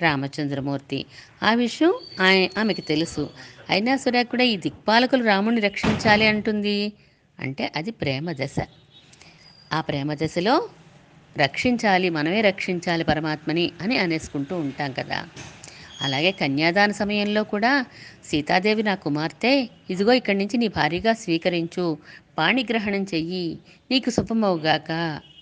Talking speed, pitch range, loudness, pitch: 105 wpm, 155-215 Hz, -22 LUFS, 185 Hz